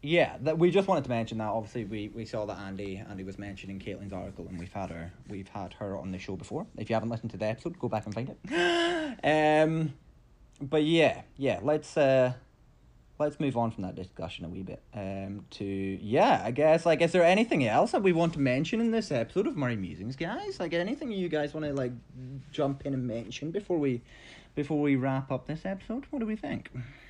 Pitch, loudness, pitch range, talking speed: 125 Hz, -30 LUFS, 100-155 Hz, 225 wpm